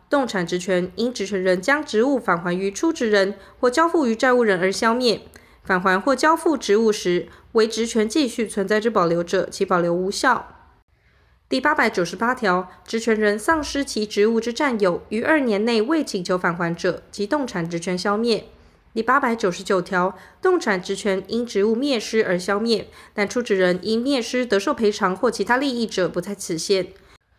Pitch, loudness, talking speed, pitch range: 210 Hz, -21 LUFS, 275 characters per minute, 185-240 Hz